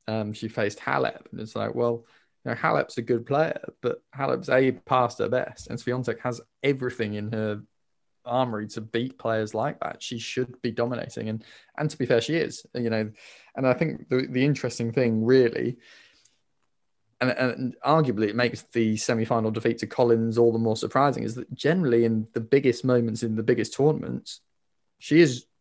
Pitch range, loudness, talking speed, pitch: 110-125 Hz, -26 LUFS, 185 wpm, 120 Hz